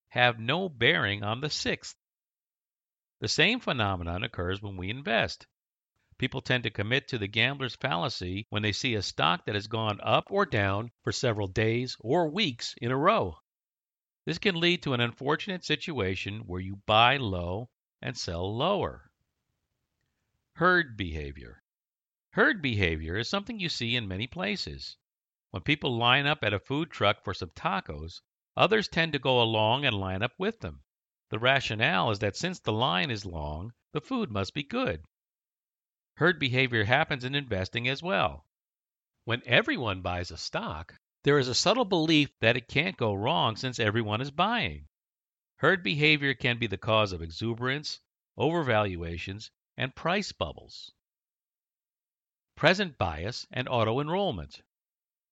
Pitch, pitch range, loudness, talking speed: 115 Hz, 100-140 Hz, -28 LUFS, 155 wpm